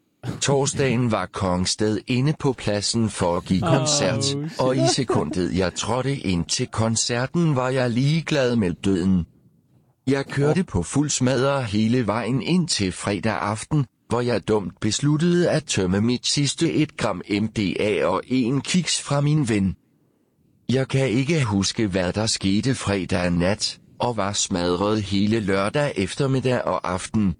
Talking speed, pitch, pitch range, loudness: 150 wpm, 120 Hz, 100-135 Hz, -22 LUFS